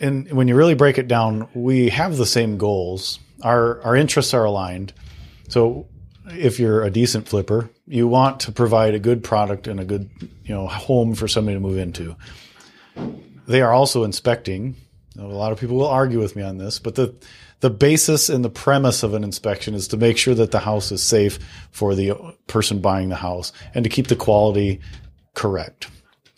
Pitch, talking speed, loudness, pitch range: 110 Hz, 195 wpm, -19 LUFS, 100-125 Hz